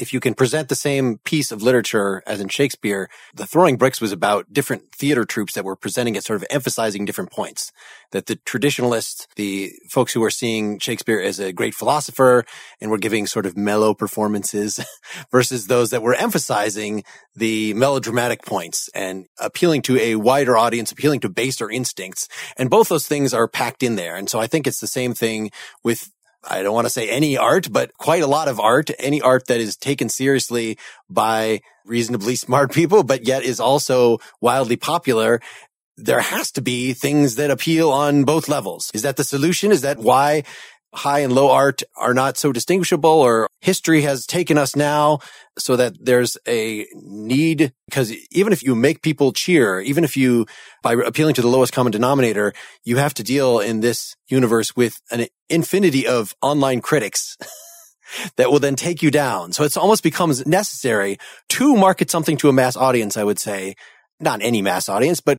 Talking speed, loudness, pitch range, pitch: 190 wpm, -19 LUFS, 115-145 Hz, 130 Hz